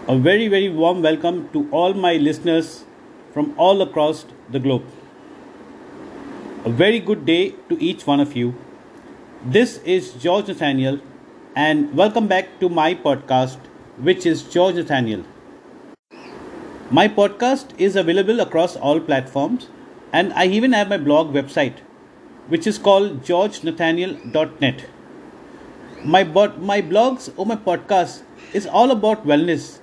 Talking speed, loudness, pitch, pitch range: 130 wpm, -18 LUFS, 180 Hz, 150-210 Hz